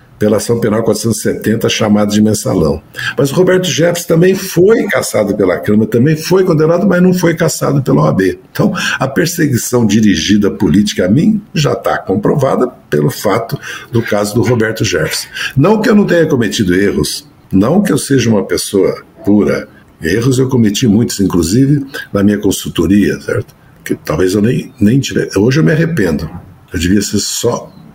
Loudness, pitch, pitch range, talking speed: -12 LUFS, 120 Hz, 105-165 Hz, 170 wpm